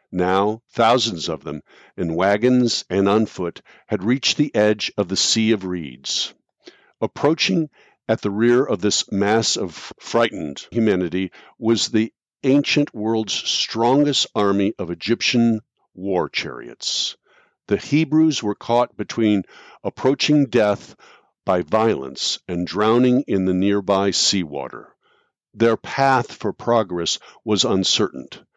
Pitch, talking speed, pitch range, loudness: 110 Hz, 125 wpm, 100-125 Hz, -20 LUFS